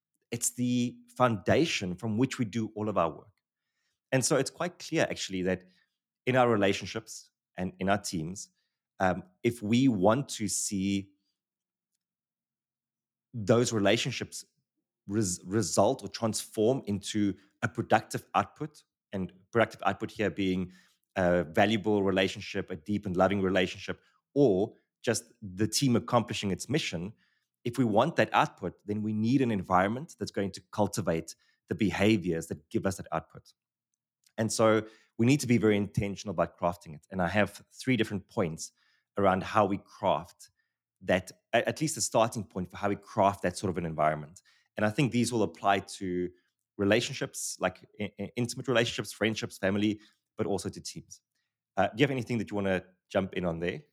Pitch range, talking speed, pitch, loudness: 95-115 Hz, 165 wpm, 105 Hz, -30 LUFS